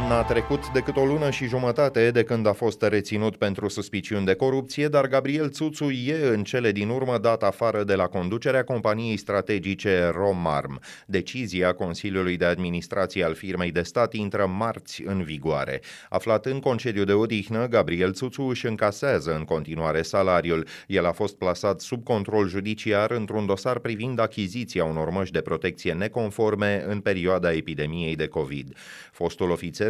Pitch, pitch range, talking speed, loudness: 105 Hz, 90-120 Hz, 160 wpm, -25 LUFS